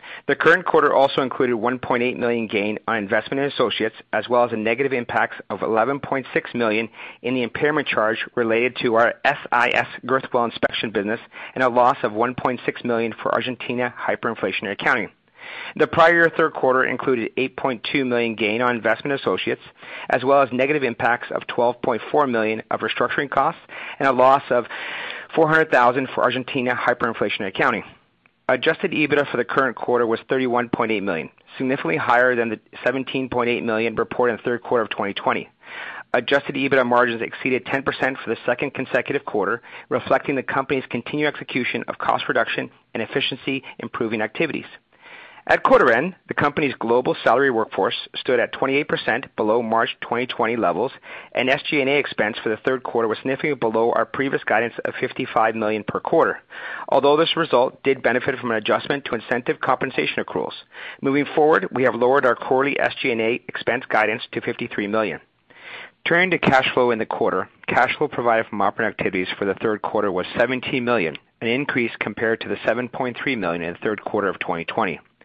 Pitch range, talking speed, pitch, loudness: 115-140 Hz, 175 wpm, 125 Hz, -21 LUFS